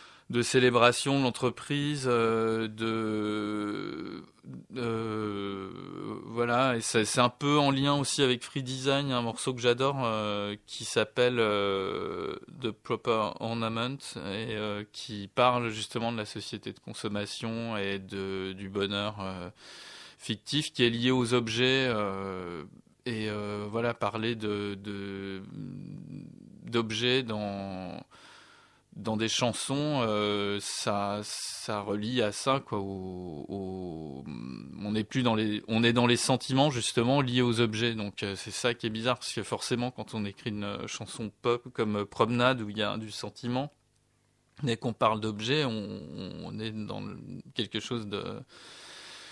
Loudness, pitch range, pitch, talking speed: -30 LUFS, 105-125 Hz, 110 Hz, 150 wpm